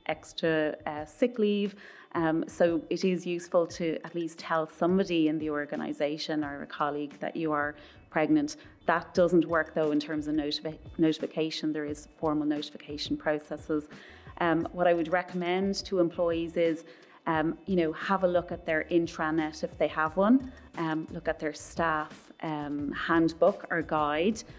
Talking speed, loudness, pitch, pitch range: 165 wpm, -30 LUFS, 160 Hz, 155-175 Hz